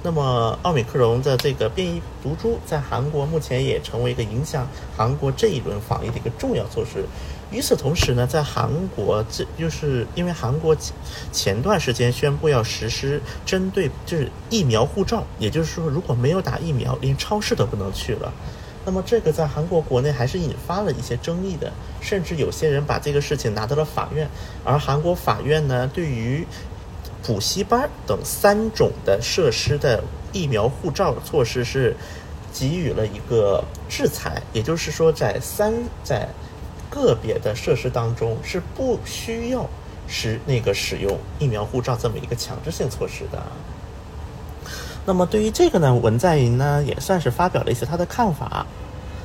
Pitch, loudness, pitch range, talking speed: 135 Hz, -22 LUFS, 115-160 Hz, 265 characters per minute